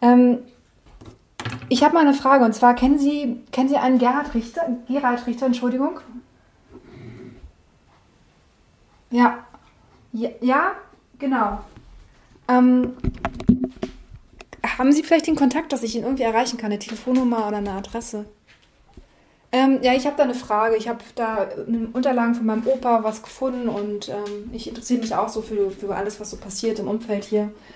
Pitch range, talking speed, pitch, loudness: 220-260 Hz, 160 wpm, 245 Hz, -21 LUFS